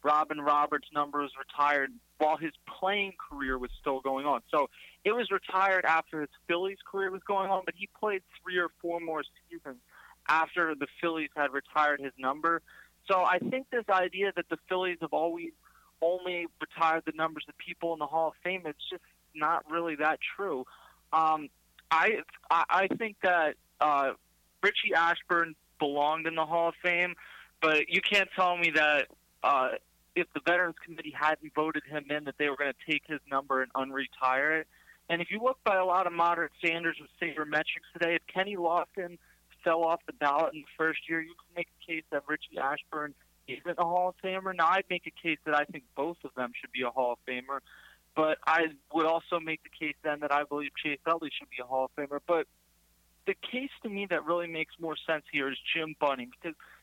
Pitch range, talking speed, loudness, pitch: 150-175 Hz, 205 wpm, -30 LUFS, 160 Hz